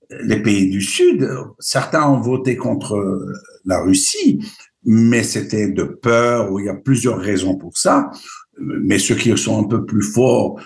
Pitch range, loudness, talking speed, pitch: 100-135 Hz, -17 LUFS, 170 wpm, 115 Hz